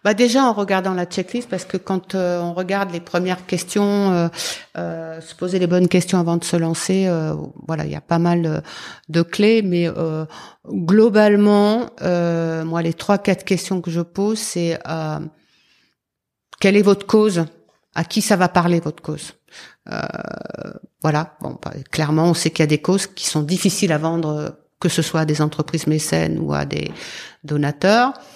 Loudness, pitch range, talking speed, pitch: -19 LUFS, 160-195 Hz, 190 wpm, 175 Hz